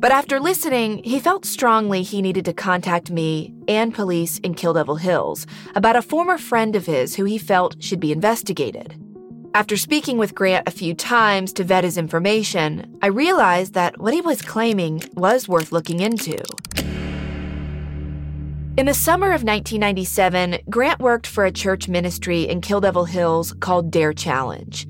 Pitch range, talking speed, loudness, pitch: 170-220 Hz, 165 wpm, -20 LUFS, 185 Hz